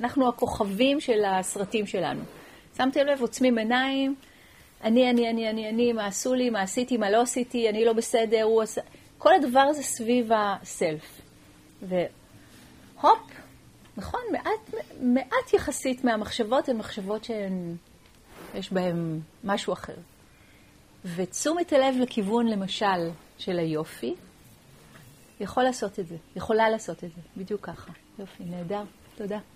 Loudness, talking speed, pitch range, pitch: -26 LUFS, 130 wpm, 195-255 Hz, 225 Hz